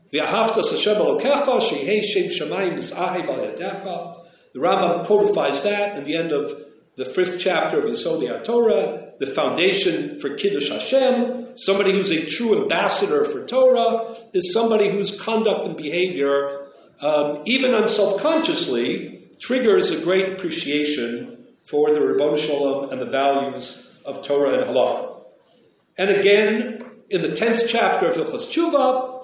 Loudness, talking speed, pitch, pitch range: -20 LUFS, 125 wpm, 205 Hz, 170-255 Hz